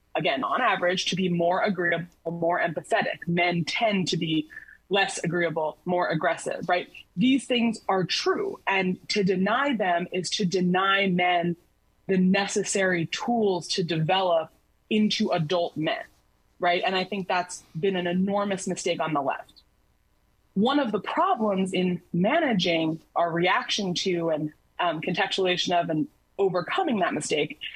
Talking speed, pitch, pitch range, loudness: 145 wpm, 185 Hz, 175-200 Hz, -25 LUFS